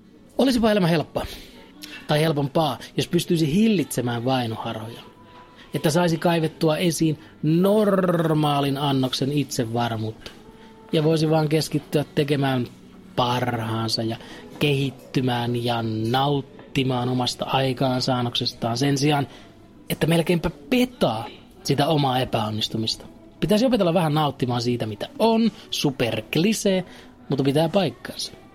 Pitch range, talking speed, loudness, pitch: 120-165 Hz, 100 wpm, -23 LUFS, 140 Hz